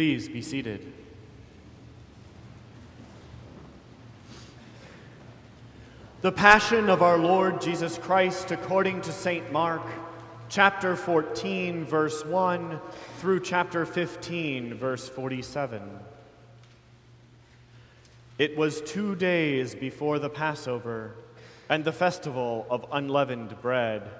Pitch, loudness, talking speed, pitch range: 145 Hz, -26 LUFS, 90 wpm, 120-175 Hz